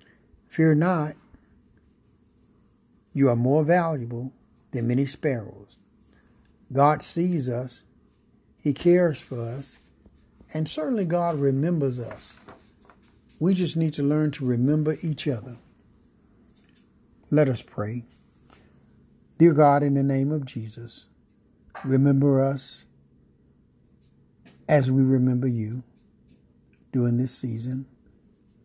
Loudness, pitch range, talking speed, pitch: -24 LUFS, 120-150 Hz, 105 wpm, 135 Hz